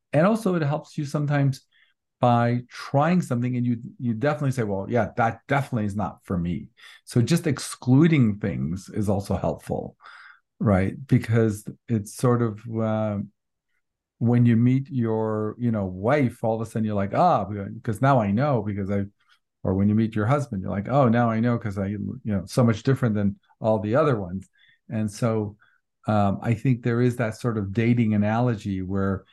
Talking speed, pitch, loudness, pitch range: 190 wpm, 115 Hz, -24 LUFS, 105-125 Hz